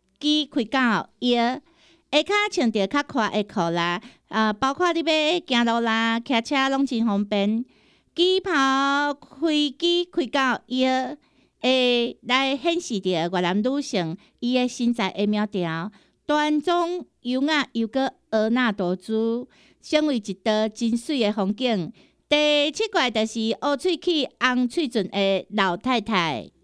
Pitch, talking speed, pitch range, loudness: 250 Hz, 190 characters per minute, 215-295 Hz, -23 LUFS